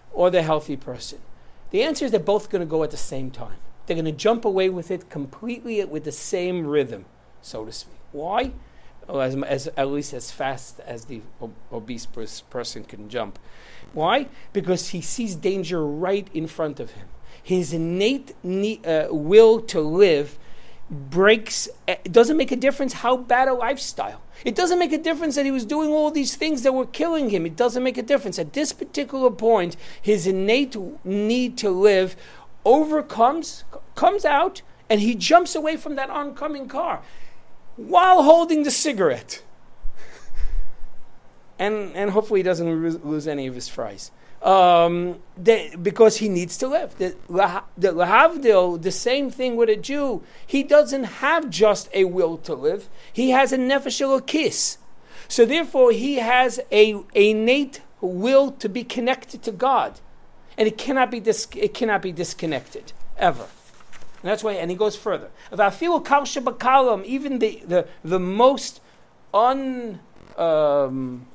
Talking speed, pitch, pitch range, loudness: 165 wpm, 215 Hz, 175-270 Hz, -21 LUFS